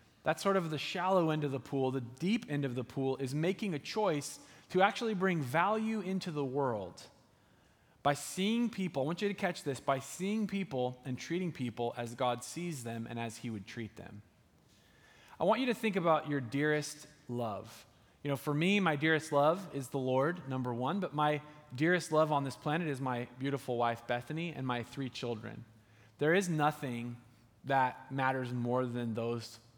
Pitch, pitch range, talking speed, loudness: 140 Hz, 120-165 Hz, 195 wpm, -34 LUFS